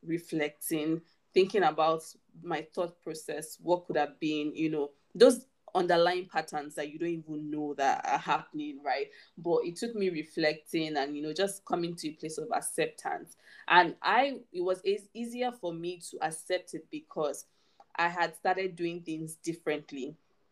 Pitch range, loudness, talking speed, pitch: 155-195 Hz, -31 LUFS, 165 wpm, 170 Hz